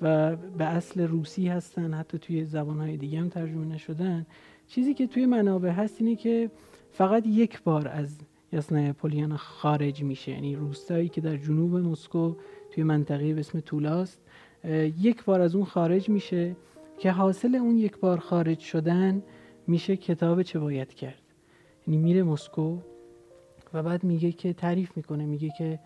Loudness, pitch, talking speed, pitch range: -28 LUFS, 170 Hz, 155 wpm, 155-185 Hz